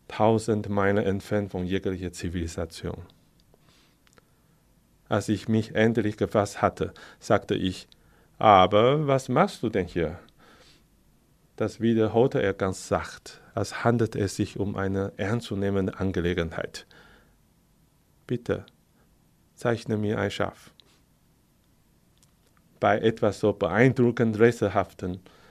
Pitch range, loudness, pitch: 95-110 Hz, -26 LUFS, 105 Hz